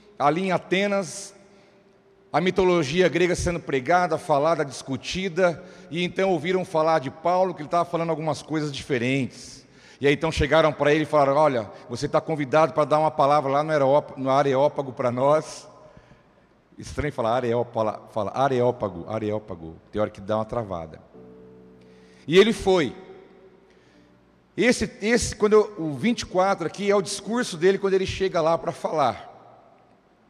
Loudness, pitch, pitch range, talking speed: -23 LUFS, 155 Hz, 130-185 Hz, 150 wpm